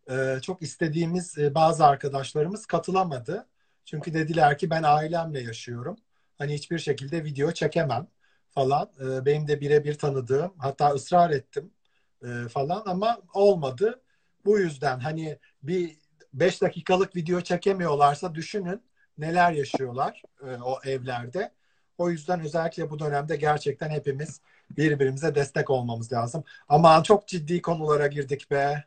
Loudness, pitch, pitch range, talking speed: -26 LUFS, 155 Hz, 140-175 Hz, 120 wpm